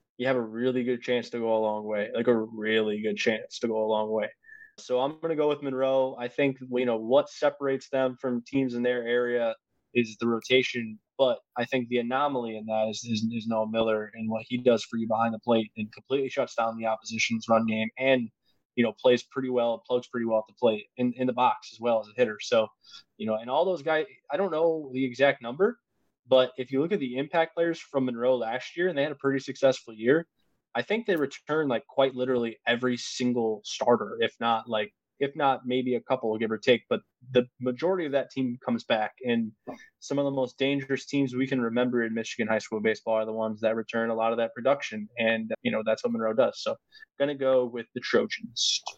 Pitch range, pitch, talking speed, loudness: 115-135 Hz, 125 Hz, 235 wpm, -28 LUFS